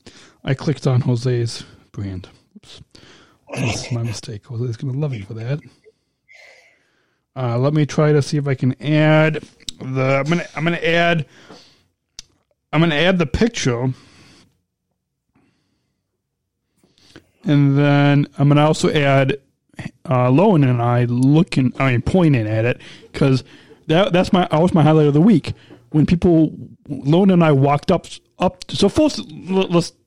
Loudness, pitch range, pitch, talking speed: -17 LUFS, 130-165 Hz, 145 Hz, 150 wpm